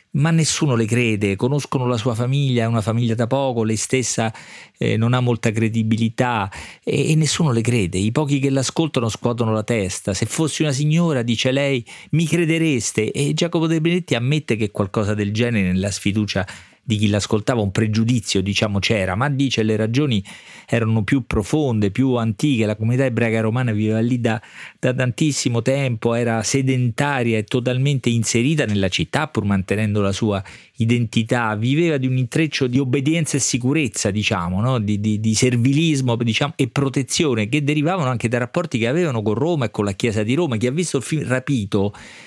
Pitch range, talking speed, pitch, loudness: 110-140 Hz, 180 wpm, 120 Hz, -20 LUFS